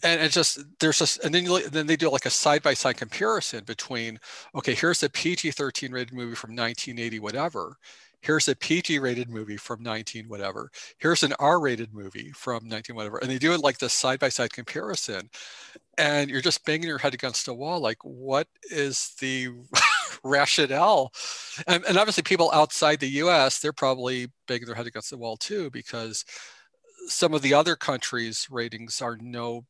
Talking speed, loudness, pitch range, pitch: 185 wpm, -25 LUFS, 120-155 Hz, 130 Hz